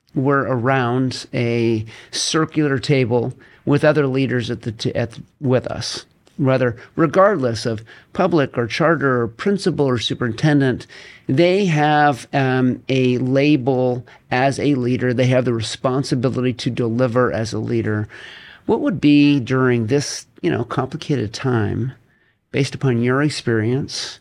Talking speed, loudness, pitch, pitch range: 135 wpm, -19 LUFS, 130 Hz, 120-145 Hz